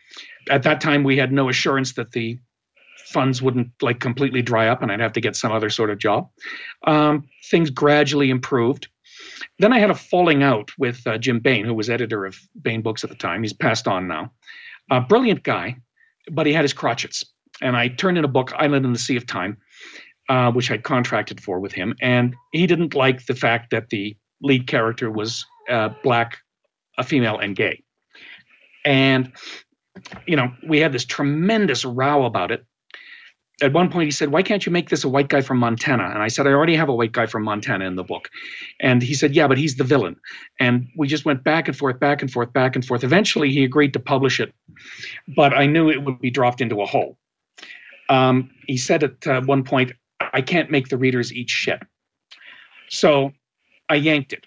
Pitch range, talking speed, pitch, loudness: 120-150 Hz, 210 wpm, 135 Hz, -20 LUFS